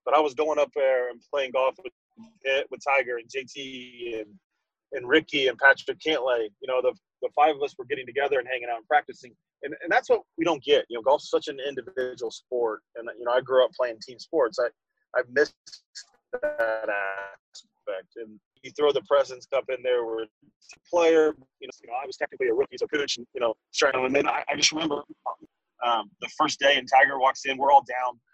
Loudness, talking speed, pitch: -25 LUFS, 220 wpm, 150 Hz